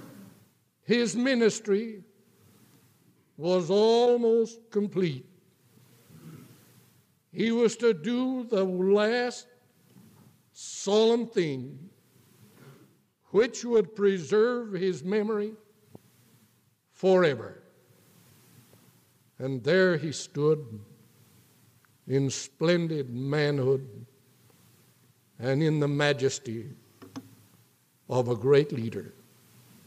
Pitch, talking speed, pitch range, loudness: 185 Hz, 70 wpm, 135-215 Hz, -27 LUFS